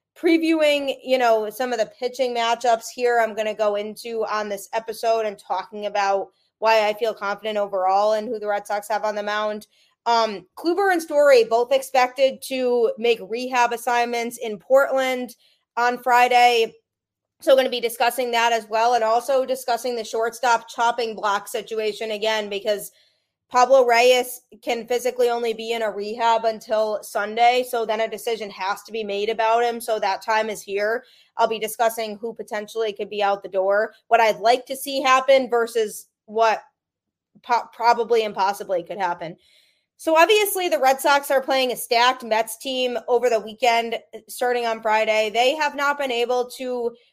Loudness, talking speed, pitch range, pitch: -21 LUFS, 175 wpm, 215-250 Hz, 230 Hz